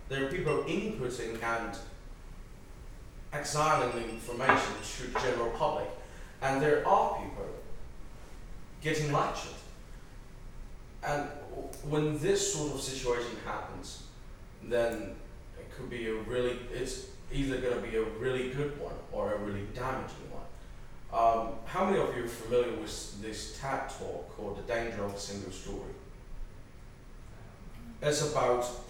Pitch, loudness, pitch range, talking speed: 120 Hz, -33 LUFS, 115-135 Hz, 135 wpm